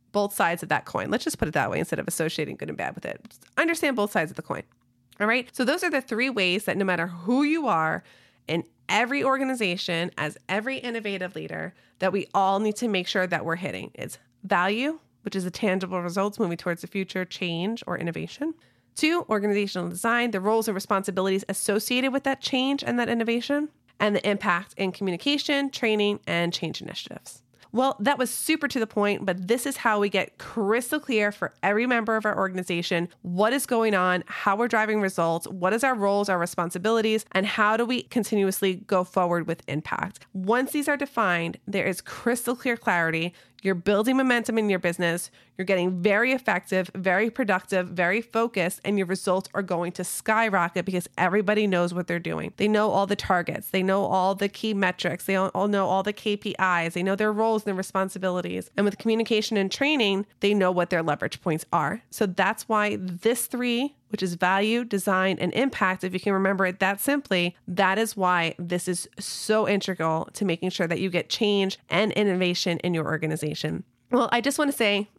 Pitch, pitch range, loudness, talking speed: 200 Hz, 180-225 Hz, -25 LUFS, 200 wpm